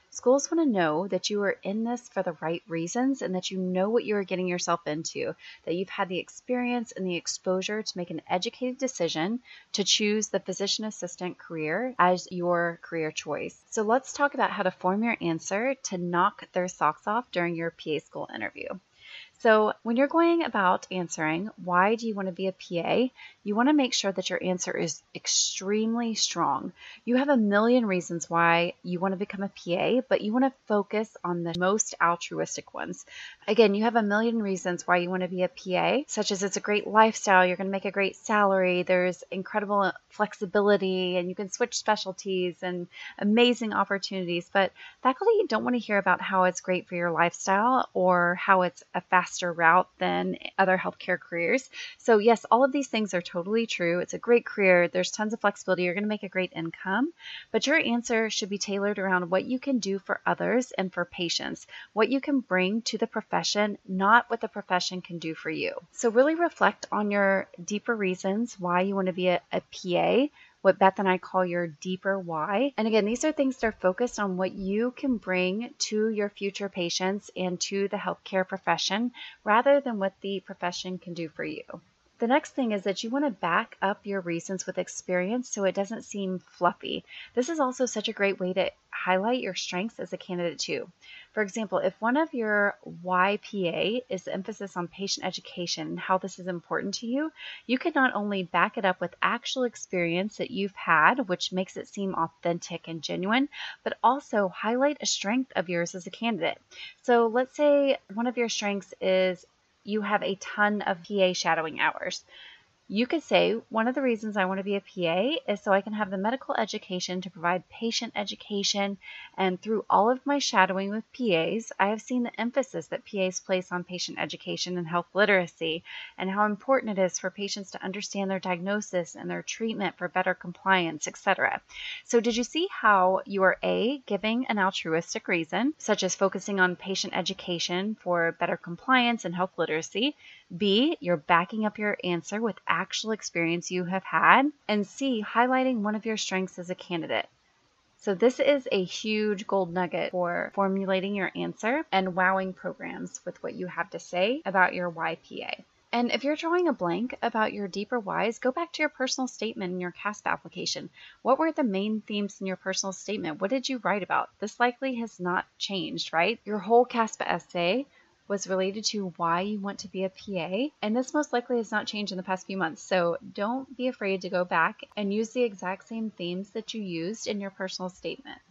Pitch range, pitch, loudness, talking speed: 180-230 Hz, 195 Hz, -27 LUFS, 200 wpm